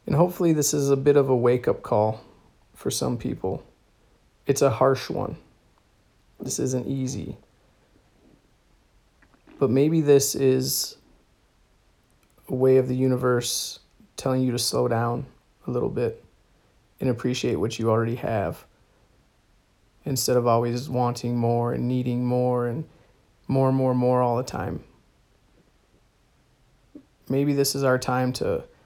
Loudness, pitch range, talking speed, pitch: -24 LUFS, 120-135 Hz, 135 wpm, 125 Hz